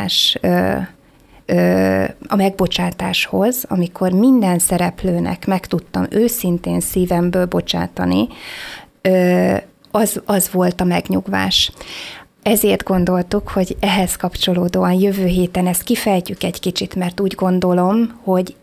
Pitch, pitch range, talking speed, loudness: 185 Hz, 175-195 Hz, 95 wpm, -17 LUFS